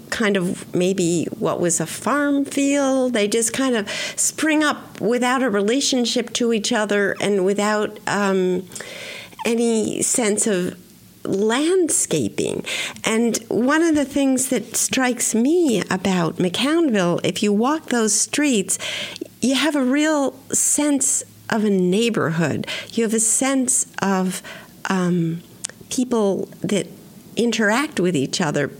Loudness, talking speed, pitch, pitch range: -20 LUFS, 130 wpm, 225 Hz, 195-265 Hz